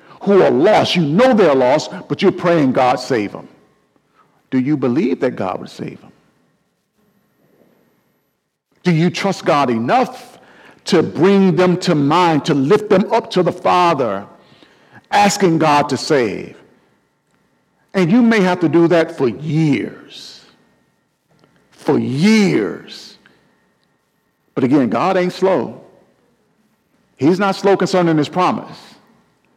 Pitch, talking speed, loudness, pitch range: 180 Hz, 130 wpm, -15 LUFS, 160-195 Hz